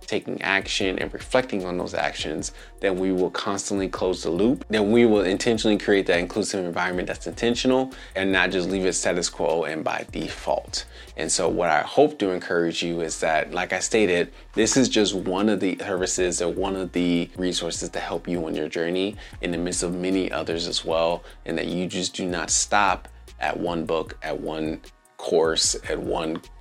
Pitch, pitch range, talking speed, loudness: 90 Hz, 85-100 Hz, 200 wpm, -24 LUFS